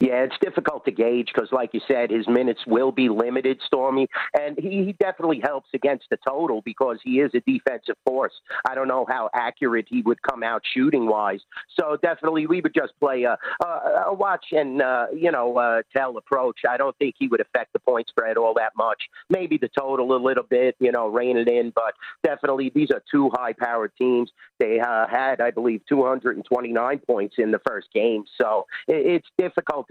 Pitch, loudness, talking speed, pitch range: 130 Hz, -23 LUFS, 195 wpm, 120-150 Hz